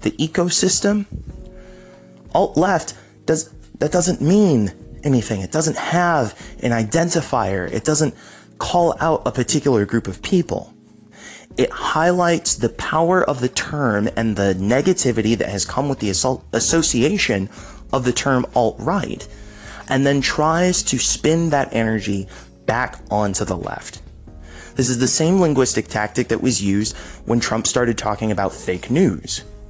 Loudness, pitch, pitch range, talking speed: -18 LUFS, 125 Hz, 105-155 Hz, 145 wpm